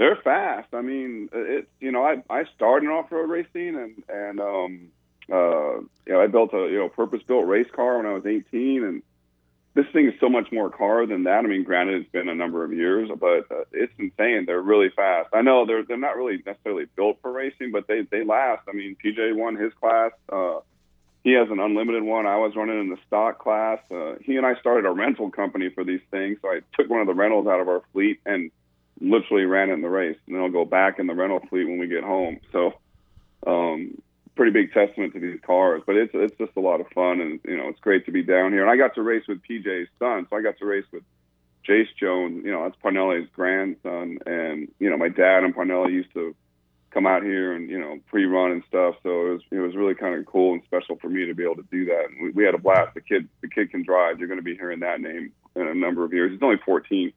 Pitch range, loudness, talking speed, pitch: 90-125 Hz, -23 LUFS, 255 wpm, 100 Hz